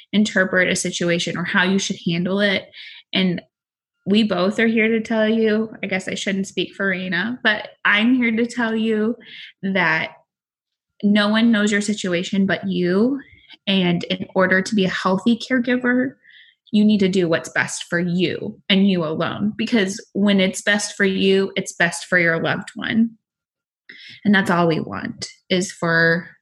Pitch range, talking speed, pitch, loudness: 180-220 Hz, 175 wpm, 195 Hz, -19 LUFS